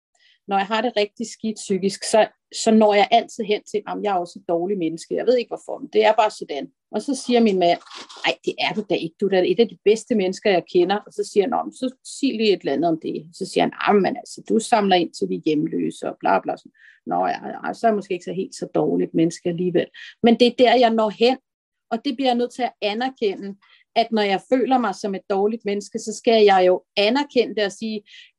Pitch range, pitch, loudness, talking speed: 195-245 Hz, 215 Hz, -21 LUFS, 270 wpm